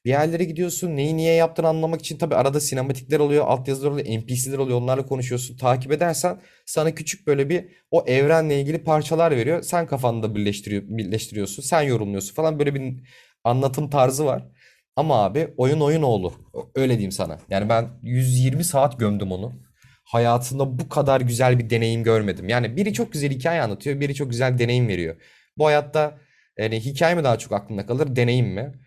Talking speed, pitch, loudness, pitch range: 180 wpm, 135 Hz, -22 LUFS, 120-155 Hz